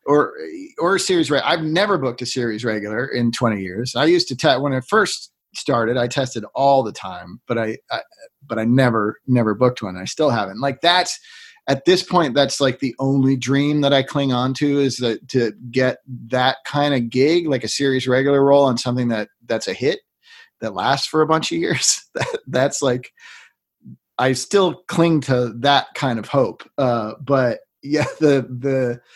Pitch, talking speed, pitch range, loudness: 135 Hz, 200 wpm, 120-150 Hz, -19 LUFS